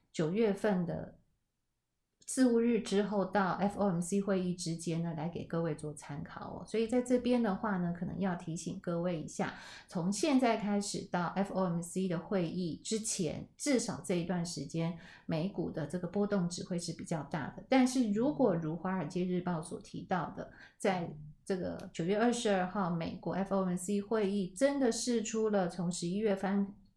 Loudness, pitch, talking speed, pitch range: -34 LUFS, 190 Hz, 270 characters per minute, 175-215 Hz